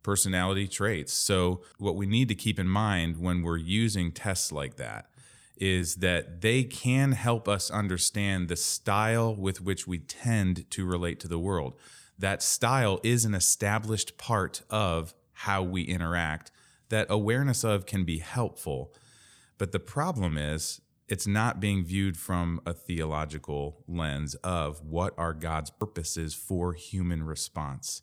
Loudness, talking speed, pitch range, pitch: -29 LUFS, 150 wpm, 85-105 Hz, 95 Hz